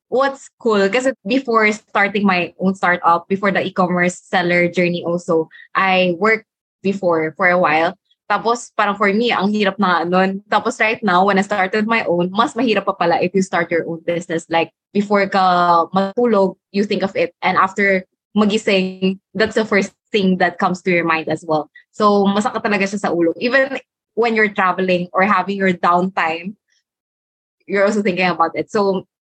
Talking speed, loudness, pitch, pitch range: 180 wpm, -17 LUFS, 190 Hz, 175-210 Hz